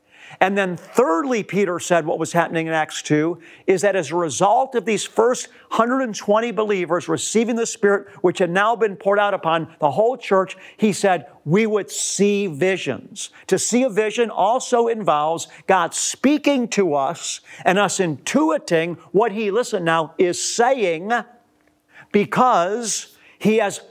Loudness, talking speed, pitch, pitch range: -20 LUFS, 155 wpm, 200 Hz, 170-225 Hz